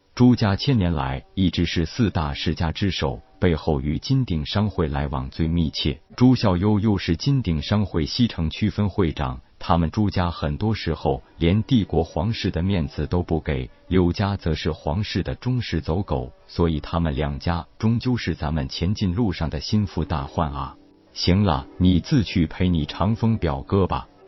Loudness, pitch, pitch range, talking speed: -23 LUFS, 85 Hz, 80-105 Hz, 255 characters per minute